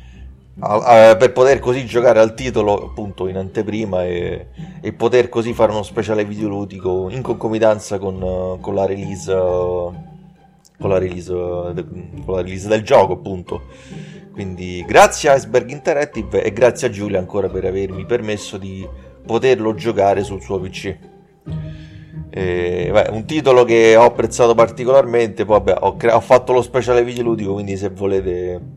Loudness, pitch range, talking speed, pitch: -16 LUFS, 95-120 Hz, 150 wpm, 105 Hz